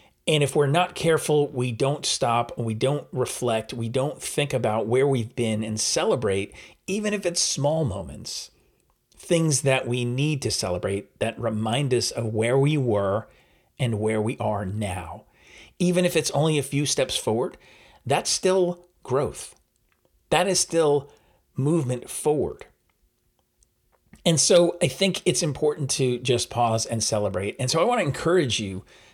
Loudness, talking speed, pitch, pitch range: -24 LUFS, 160 wpm, 135 Hz, 110-160 Hz